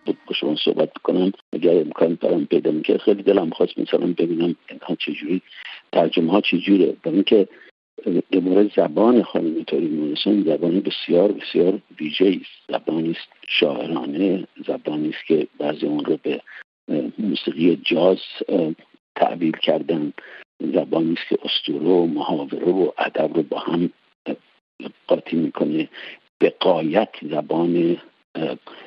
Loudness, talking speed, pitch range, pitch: -21 LUFS, 130 wpm, 80-85 Hz, 85 Hz